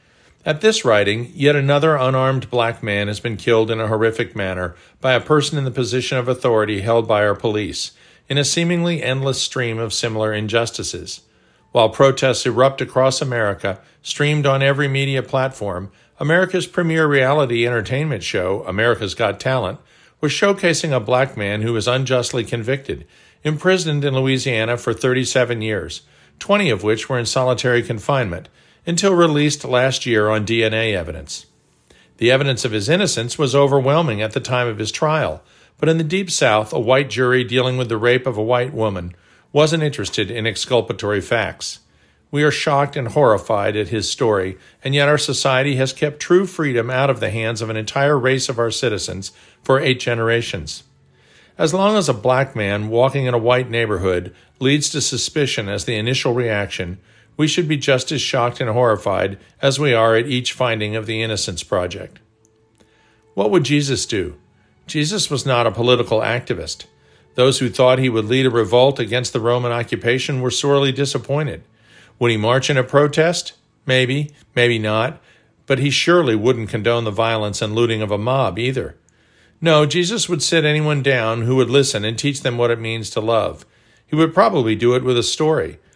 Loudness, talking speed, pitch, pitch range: -18 LUFS, 175 wpm, 125 Hz, 110-140 Hz